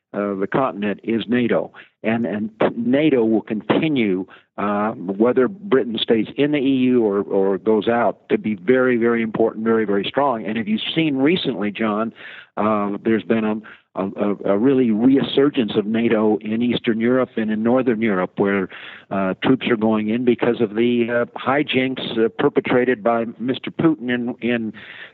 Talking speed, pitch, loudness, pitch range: 165 wpm, 115 Hz, -19 LUFS, 110-130 Hz